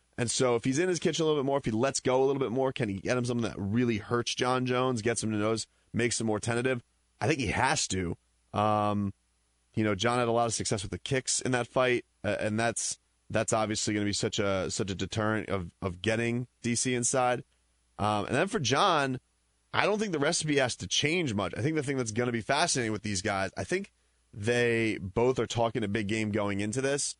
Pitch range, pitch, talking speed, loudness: 105-130 Hz, 115 Hz, 250 wpm, -29 LUFS